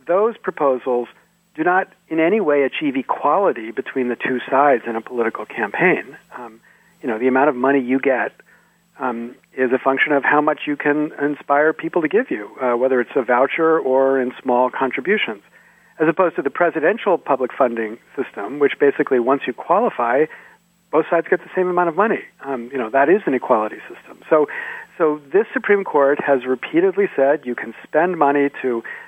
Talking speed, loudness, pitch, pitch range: 190 wpm, -19 LUFS, 145 Hz, 130-180 Hz